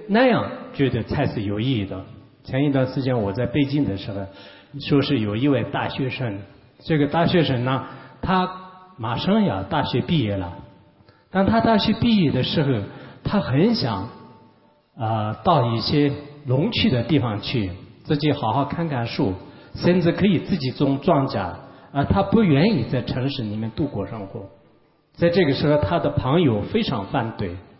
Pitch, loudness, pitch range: 135 Hz, -22 LUFS, 110-155 Hz